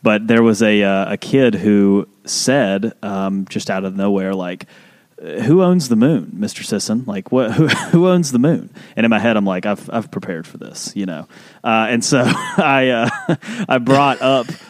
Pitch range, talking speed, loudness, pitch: 100-165 Hz, 200 wpm, -16 LUFS, 115 Hz